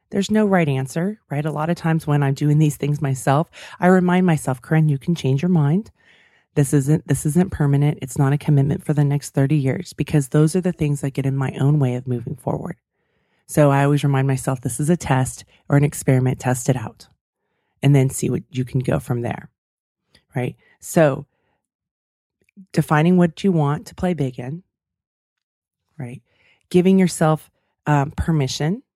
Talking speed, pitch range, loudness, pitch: 190 wpm, 135-165 Hz, -20 LUFS, 145 Hz